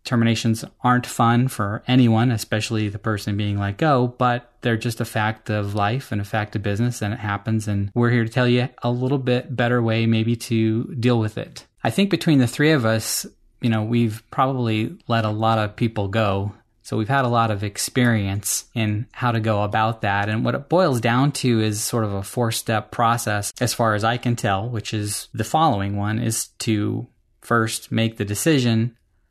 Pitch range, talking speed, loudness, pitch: 105-120 Hz, 210 wpm, -21 LUFS, 115 Hz